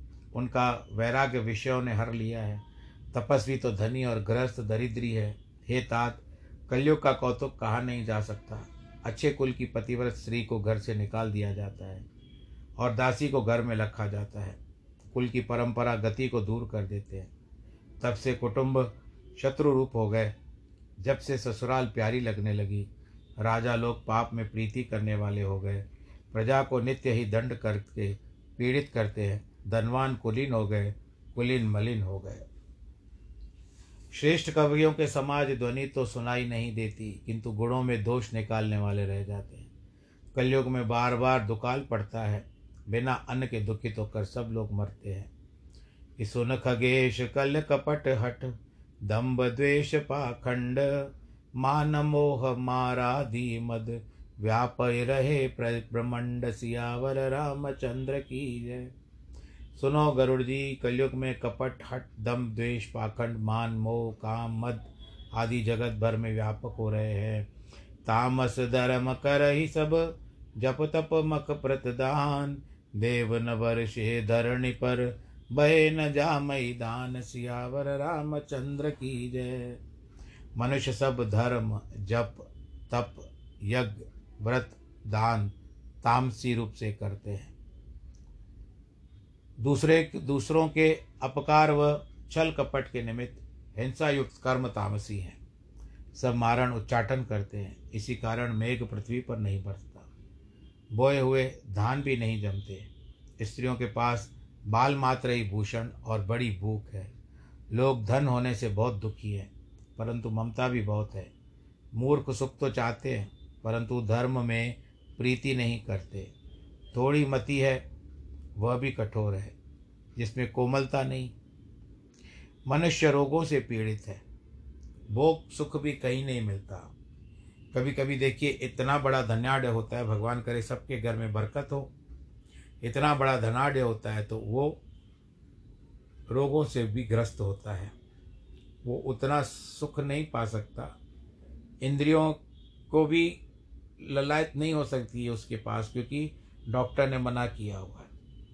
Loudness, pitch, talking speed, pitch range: -30 LUFS, 120 Hz, 140 wpm, 105-130 Hz